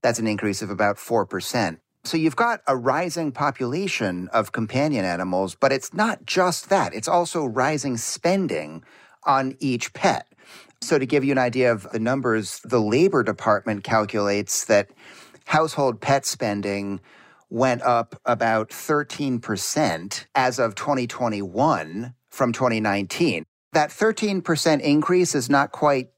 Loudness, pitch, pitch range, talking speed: -22 LUFS, 130 Hz, 110-150 Hz, 135 wpm